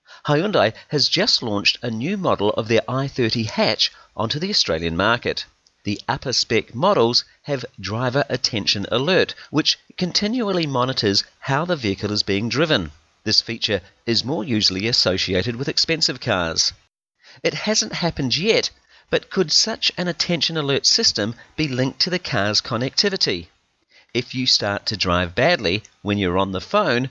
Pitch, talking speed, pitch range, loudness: 125 Hz, 155 wpm, 100-165 Hz, -20 LUFS